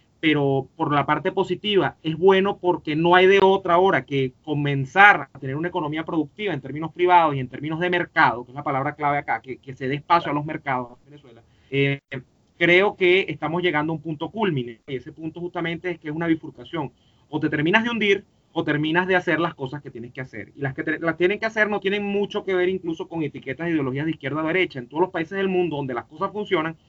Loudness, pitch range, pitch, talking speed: -22 LUFS, 140-180 Hz, 160 Hz, 245 wpm